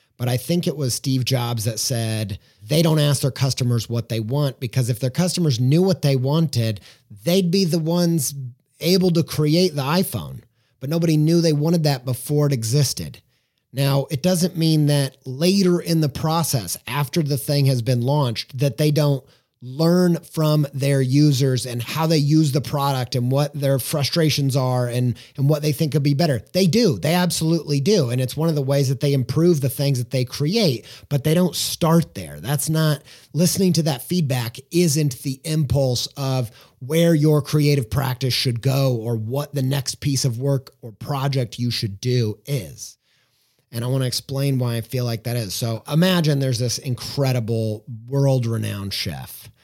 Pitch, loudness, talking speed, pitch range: 140 Hz, -20 LUFS, 190 wpm, 125-155 Hz